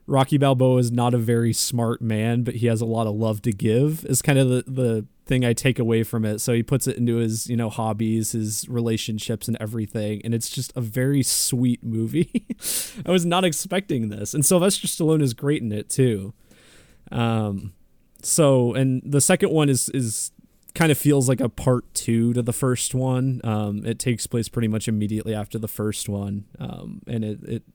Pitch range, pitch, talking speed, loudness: 110-130 Hz, 120 Hz, 205 wpm, -22 LUFS